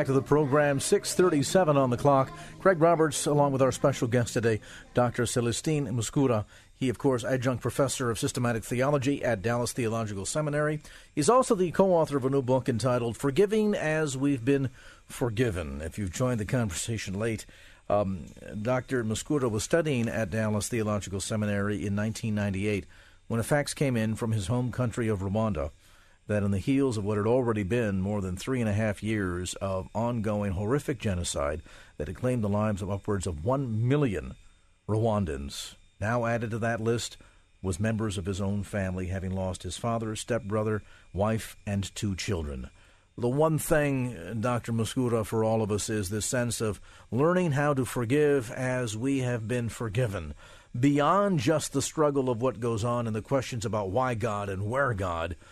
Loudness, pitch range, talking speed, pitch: -28 LUFS, 100-135 Hz, 175 wpm, 115 Hz